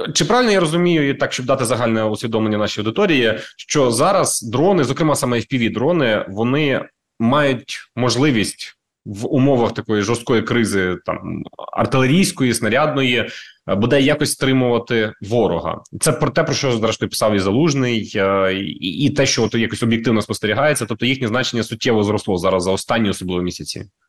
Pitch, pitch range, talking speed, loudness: 120 Hz, 110-135 Hz, 150 wpm, -18 LUFS